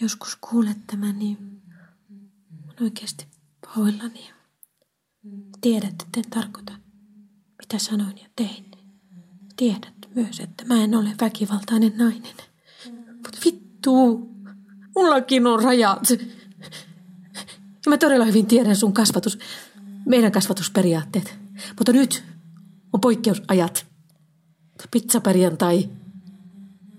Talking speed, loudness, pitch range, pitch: 90 wpm, -21 LUFS, 190-230 Hz, 205 Hz